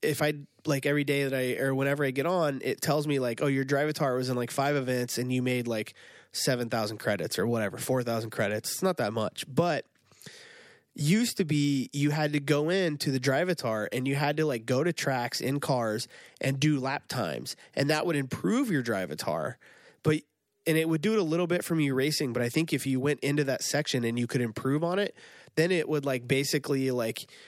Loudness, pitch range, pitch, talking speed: -29 LUFS, 125-150 Hz, 140 Hz, 225 wpm